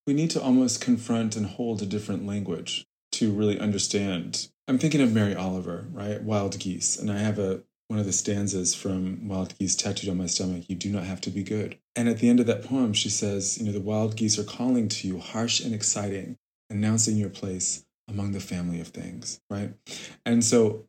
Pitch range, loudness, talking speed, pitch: 95-110 Hz, -27 LUFS, 215 wpm, 105 Hz